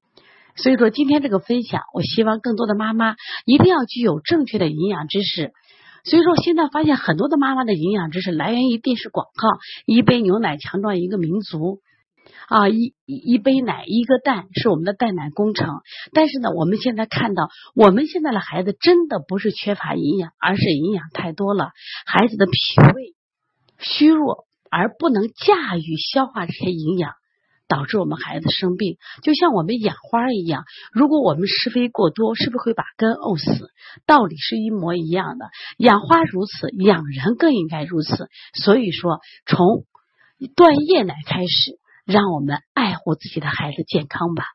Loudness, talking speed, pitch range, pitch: -19 LUFS, 270 characters per minute, 175-255 Hz, 210 Hz